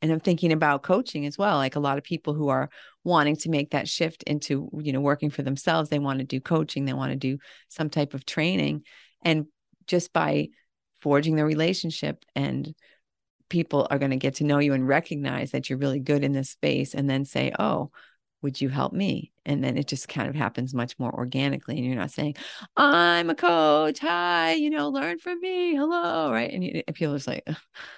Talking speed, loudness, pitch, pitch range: 215 wpm, -26 LUFS, 145 Hz, 135-165 Hz